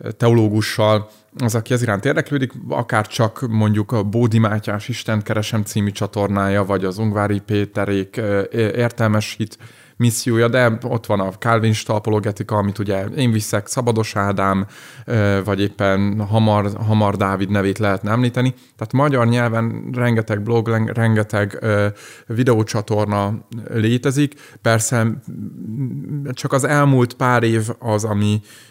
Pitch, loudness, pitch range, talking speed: 110 Hz, -19 LUFS, 105-120 Hz, 125 wpm